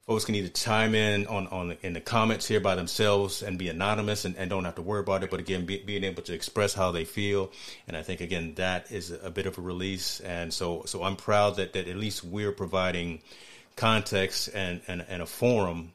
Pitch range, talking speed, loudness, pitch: 90-105 Hz, 235 wpm, -29 LUFS, 95 Hz